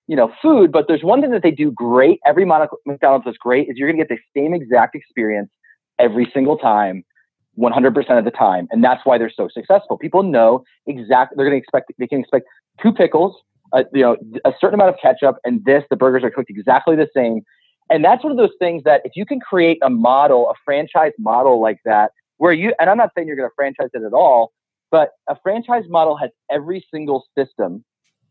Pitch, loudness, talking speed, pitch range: 140 Hz, -16 LUFS, 225 wpm, 125-175 Hz